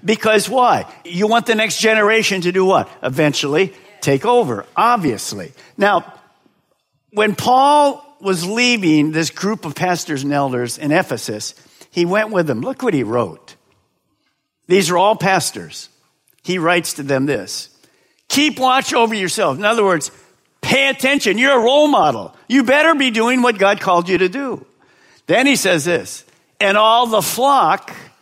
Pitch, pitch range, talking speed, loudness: 205 Hz, 175-245 Hz, 160 wpm, -15 LUFS